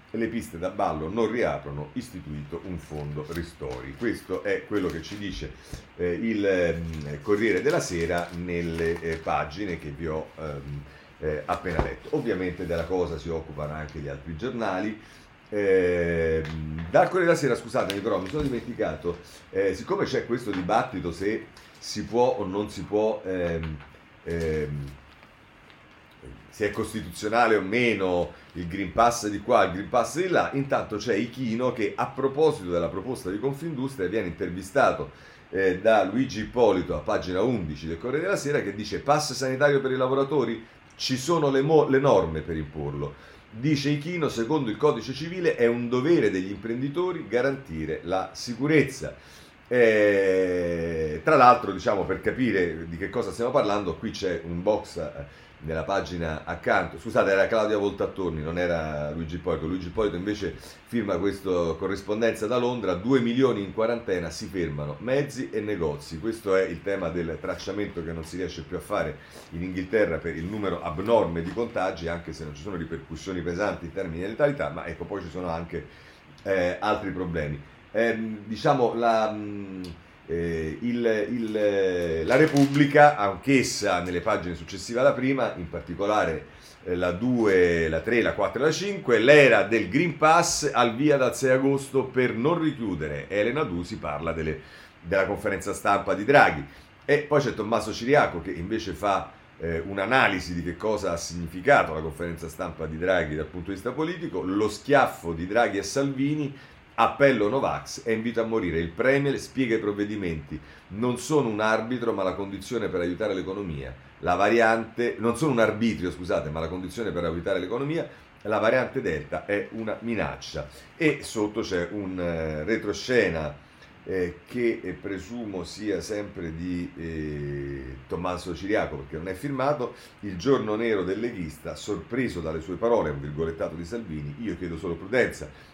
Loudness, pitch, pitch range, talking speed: -26 LUFS, 95 Hz, 85-120 Hz, 160 wpm